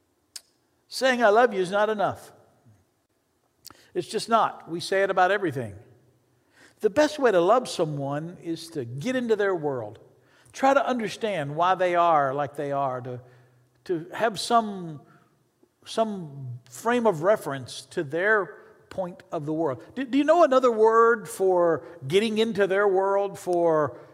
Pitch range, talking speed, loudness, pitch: 140-215 Hz, 155 wpm, -24 LUFS, 180 Hz